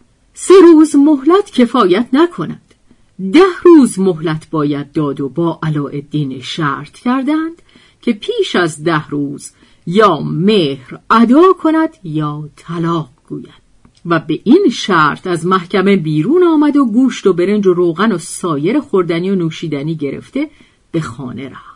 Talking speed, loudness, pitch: 140 wpm, -12 LUFS, 185 Hz